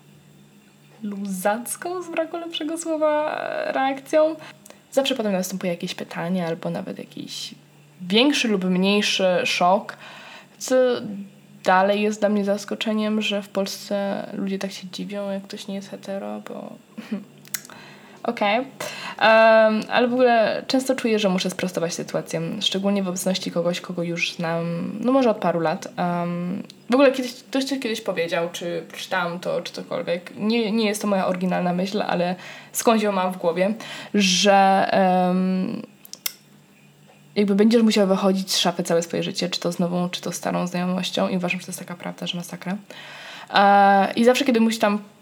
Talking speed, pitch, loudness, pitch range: 160 wpm, 200 Hz, -22 LUFS, 185-225 Hz